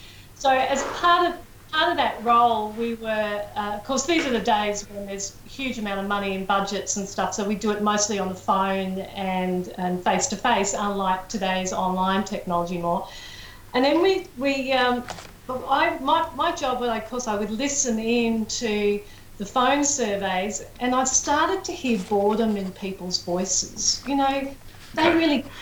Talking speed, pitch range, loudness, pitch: 185 wpm, 195-265 Hz, -24 LUFS, 215 Hz